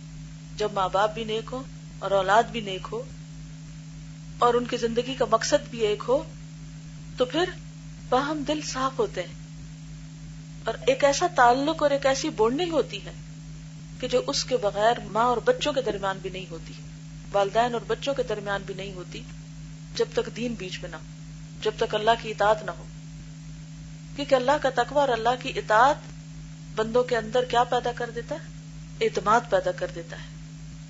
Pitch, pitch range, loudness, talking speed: 190 Hz, 155-235 Hz, -25 LUFS, 180 wpm